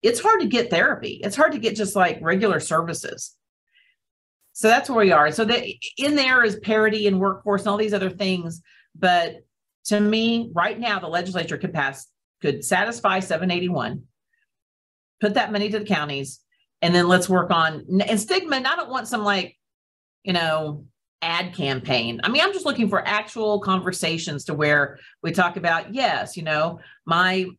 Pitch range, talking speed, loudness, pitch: 165-215 Hz, 185 wpm, -21 LUFS, 190 Hz